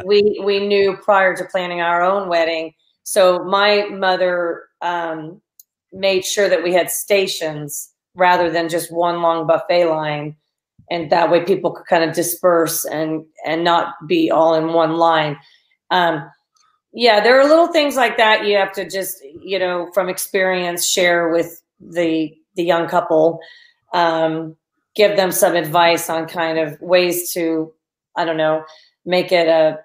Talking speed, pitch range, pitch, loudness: 160 wpm, 165-190 Hz, 175 Hz, -17 LUFS